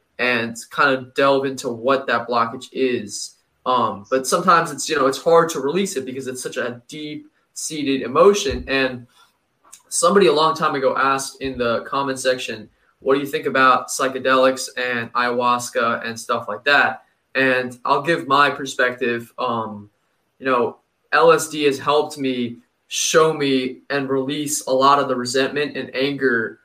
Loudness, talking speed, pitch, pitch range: -19 LUFS, 165 wpm, 130 Hz, 125-140 Hz